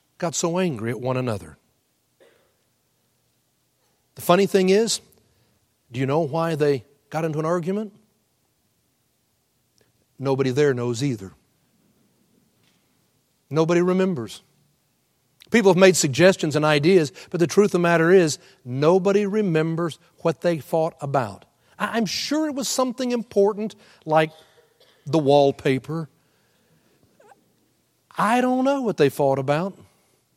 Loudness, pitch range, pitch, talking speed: -21 LUFS, 140-190 Hz, 160 Hz, 120 wpm